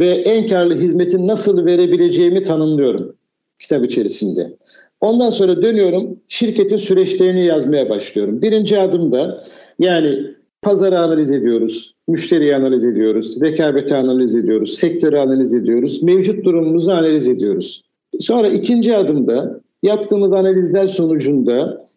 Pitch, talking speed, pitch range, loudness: 175 Hz, 110 wpm, 140-200 Hz, -15 LUFS